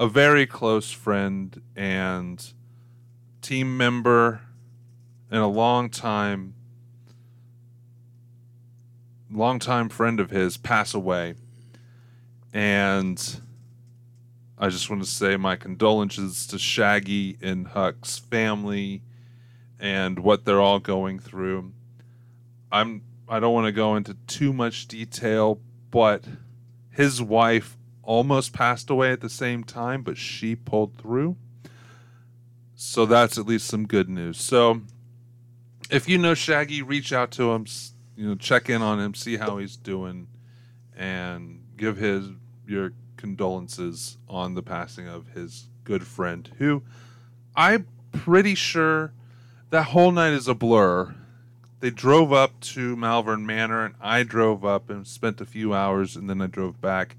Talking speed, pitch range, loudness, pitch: 135 wpm, 105-120 Hz, -23 LUFS, 120 Hz